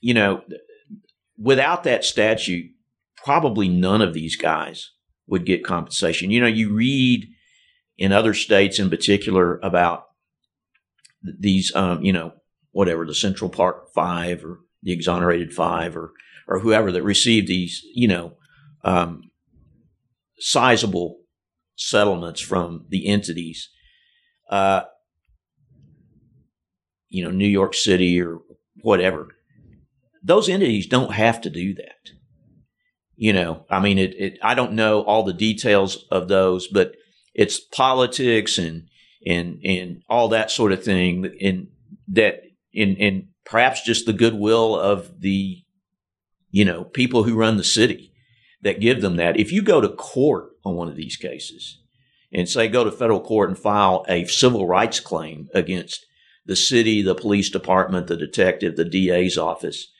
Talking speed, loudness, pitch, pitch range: 145 wpm, -20 LUFS, 100 Hz, 90-115 Hz